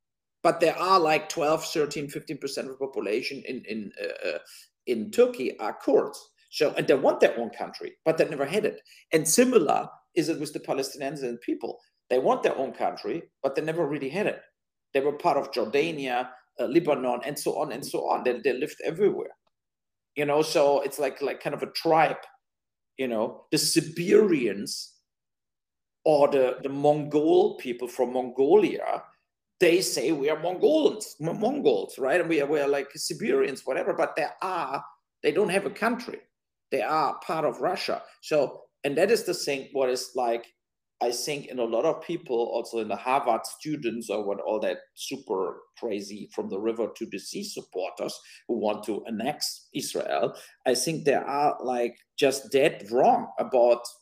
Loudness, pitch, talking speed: -27 LUFS, 155 Hz, 180 wpm